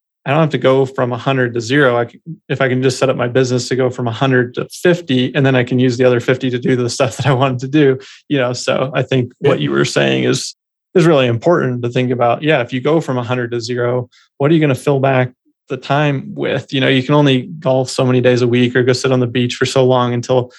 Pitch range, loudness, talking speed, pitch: 125-135 Hz, -15 LUFS, 285 wpm, 130 Hz